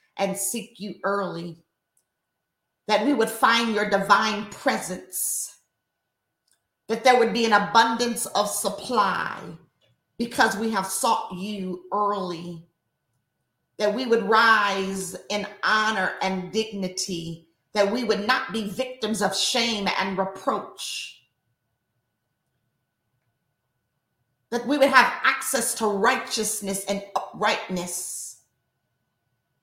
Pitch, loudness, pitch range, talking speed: 195 Hz, -23 LUFS, 165-225 Hz, 105 wpm